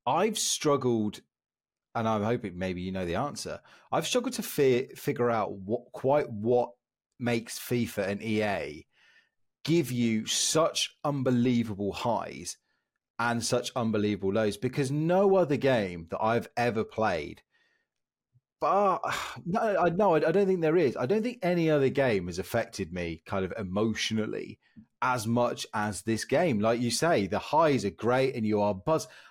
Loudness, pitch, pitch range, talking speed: -28 LUFS, 120 Hz, 105-145 Hz, 155 wpm